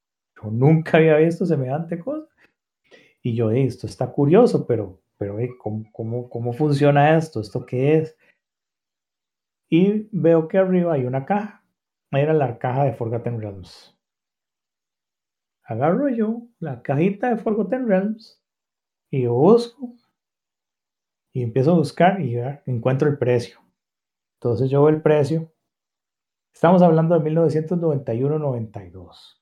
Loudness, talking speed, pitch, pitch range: -20 LUFS, 125 wpm, 150 Hz, 120-175 Hz